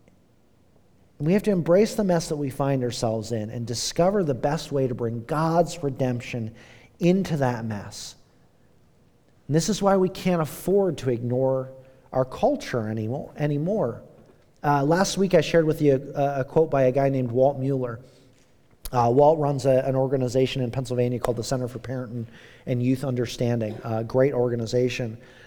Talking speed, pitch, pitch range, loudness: 165 wpm, 130 Hz, 125-150 Hz, -24 LUFS